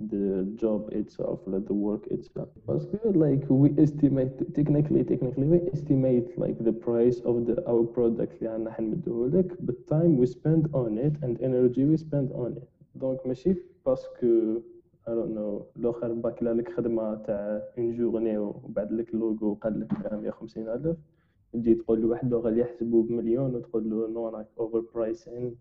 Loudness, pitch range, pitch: -27 LUFS, 115-145 Hz, 120 Hz